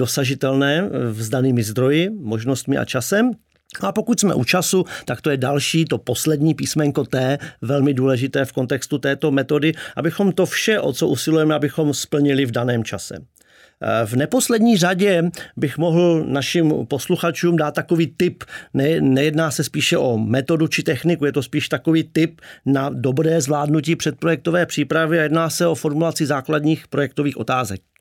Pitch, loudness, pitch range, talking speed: 155 Hz, -19 LUFS, 135-165 Hz, 155 wpm